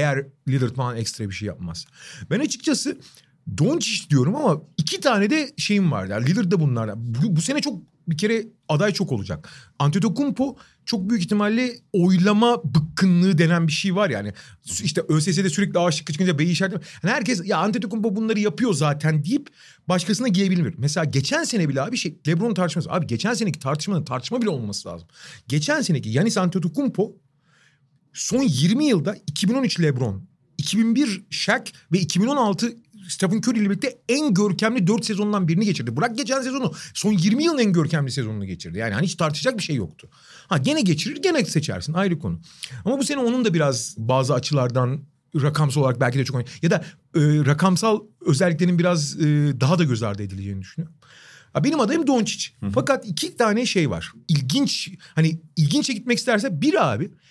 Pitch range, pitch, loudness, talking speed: 145-215 Hz, 175 Hz, -22 LUFS, 170 wpm